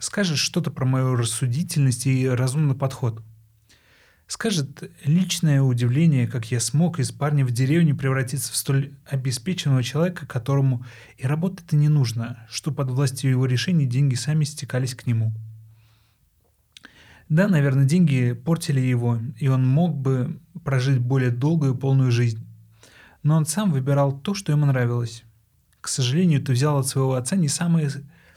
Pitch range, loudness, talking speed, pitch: 125-150 Hz, -22 LUFS, 150 wpm, 135 Hz